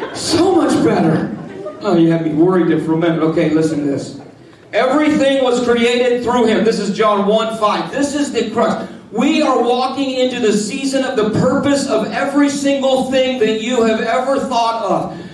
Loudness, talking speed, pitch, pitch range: -15 LUFS, 190 wpm, 235 Hz, 205-265 Hz